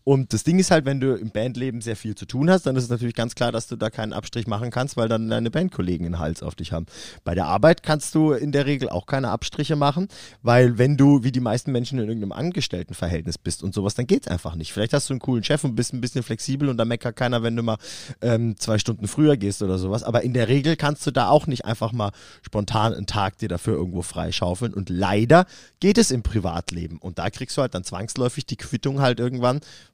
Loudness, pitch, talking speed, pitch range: -23 LUFS, 120 Hz, 250 wpm, 105-135 Hz